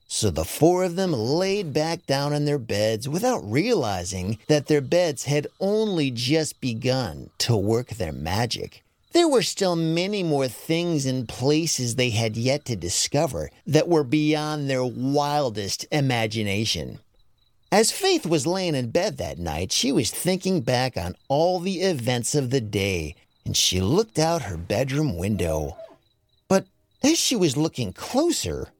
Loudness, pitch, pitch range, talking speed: -23 LUFS, 135 Hz, 110-165 Hz, 155 wpm